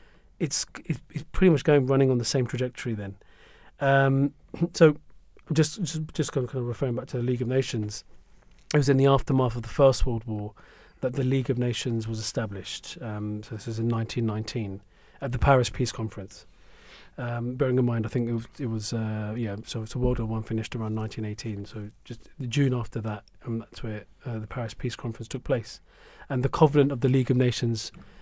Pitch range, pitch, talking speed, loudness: 110-135 Hz, 120 Hz, 215 wpm, -27 LUFS